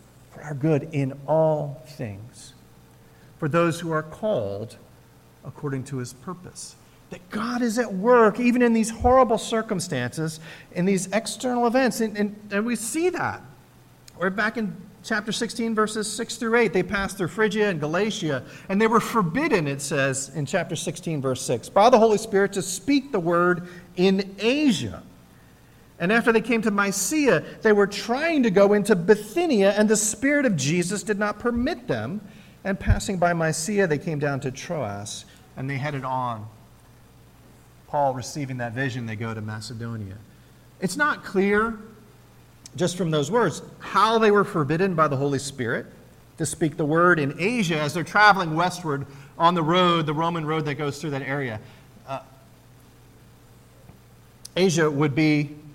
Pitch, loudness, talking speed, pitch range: 175 Hz, -23 LUFS, 165 wpm, 140-210 Hz